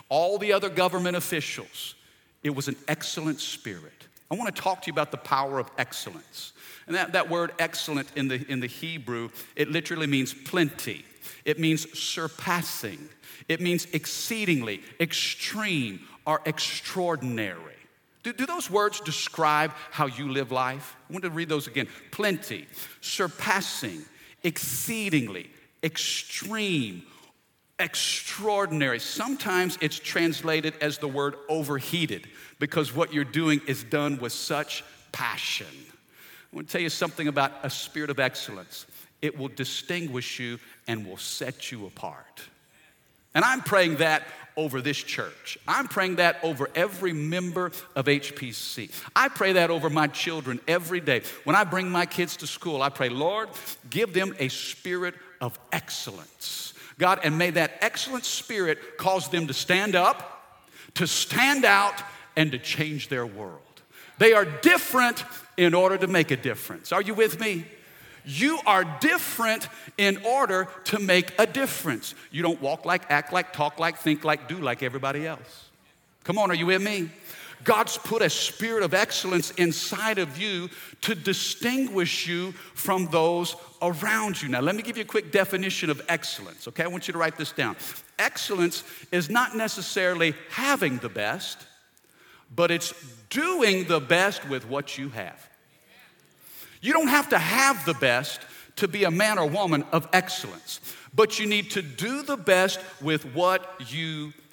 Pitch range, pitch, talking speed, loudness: 145-185 Hz, 165 Hz, 155 wpm, -26 LUFS